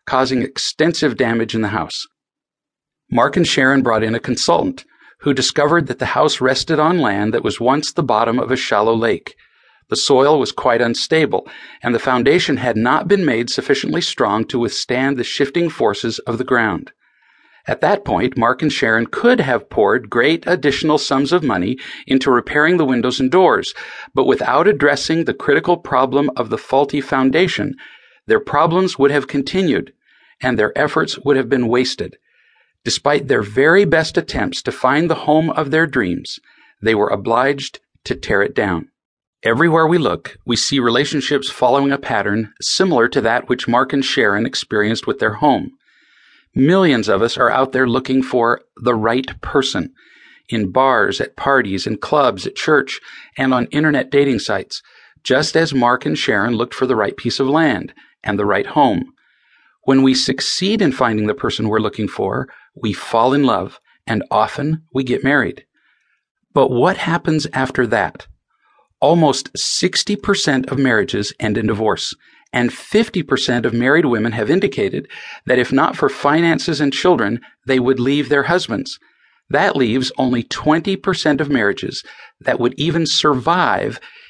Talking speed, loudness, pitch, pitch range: 165 wpm, -16 LUFS, 135 Hz, 125-155 Hz